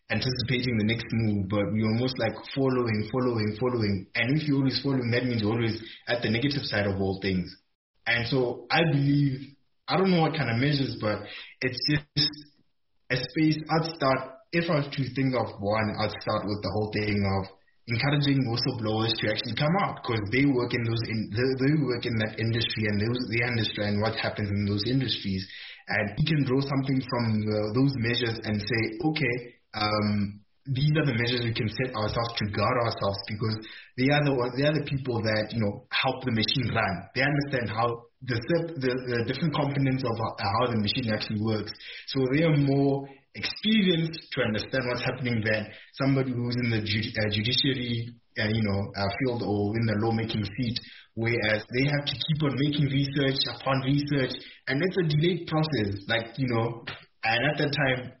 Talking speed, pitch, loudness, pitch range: 190 wpm, 120 Hz, -27 LUFS, 110-135 Hz